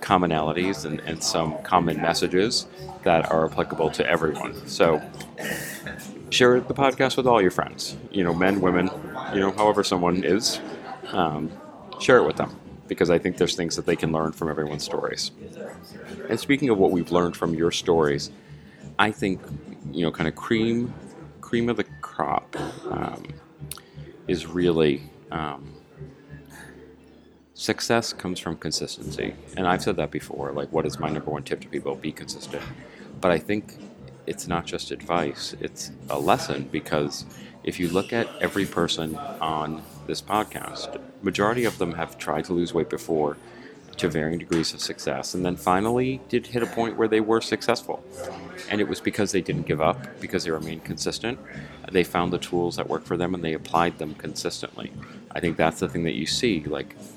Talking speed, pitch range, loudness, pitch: 175 wpm, 80-105 Hz, -25 LUFS, 90 Hz